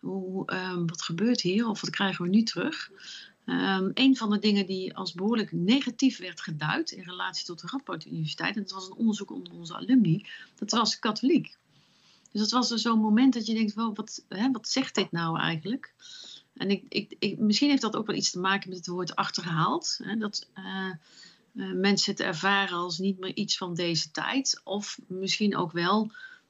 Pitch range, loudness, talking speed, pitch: 185-230 Hz, -28 LUFS, 205 wpm, 200 Hz